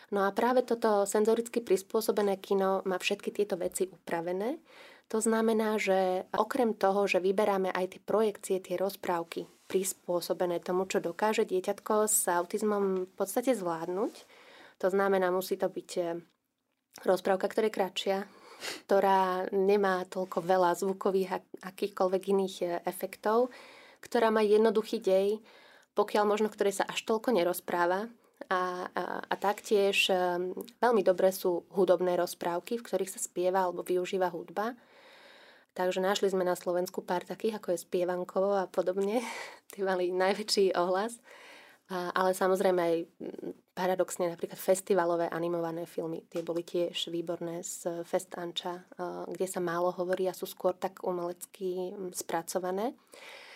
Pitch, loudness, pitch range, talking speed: 190 Hz, -31 LUFS, 180-215 Hz, 135 wpm